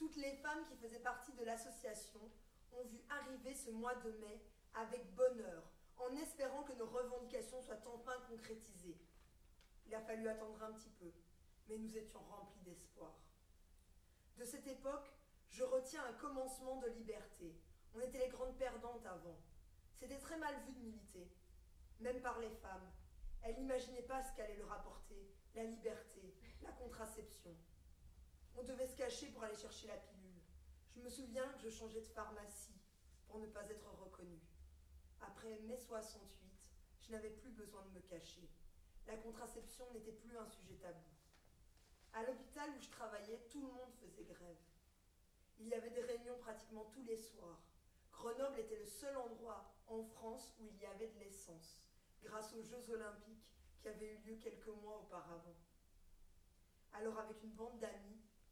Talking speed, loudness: 165 wpm, -51 LUFS